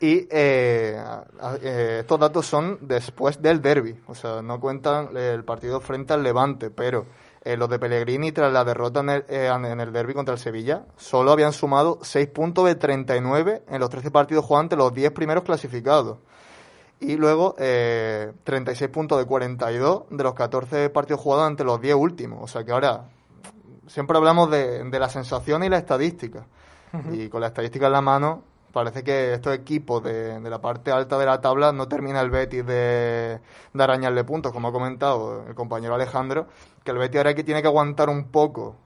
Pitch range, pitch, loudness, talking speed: 120-150 Hz, 135 Hz, -23 LUFS, 190 wpm